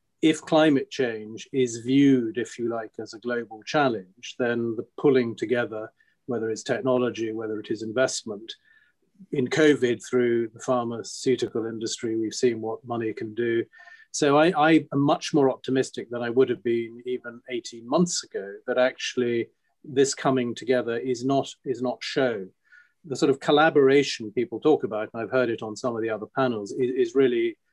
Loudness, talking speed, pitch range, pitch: -25 LUFS, 175 wpm, 115-145 Hz, 125 Hz